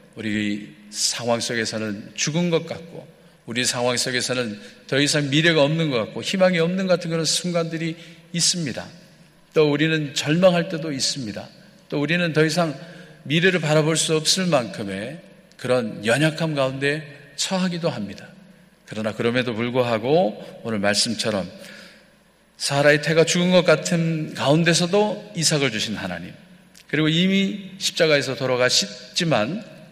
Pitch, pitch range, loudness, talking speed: 155 Hz, 125-170 Hz, -21 LUFS, 305 characters per minute